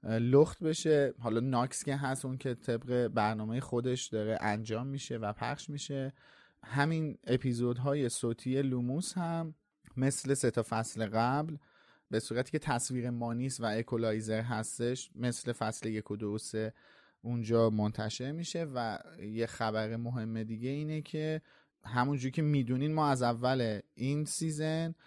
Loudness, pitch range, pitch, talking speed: -34 LUFS, 115-140 Hz, 125 Hz, 140 wpm